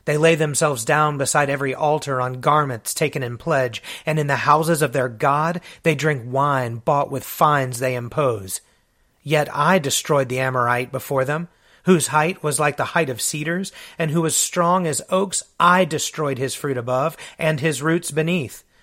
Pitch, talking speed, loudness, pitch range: 150 Hz, 180 wpm, -20 LUFS, 135-160 Hz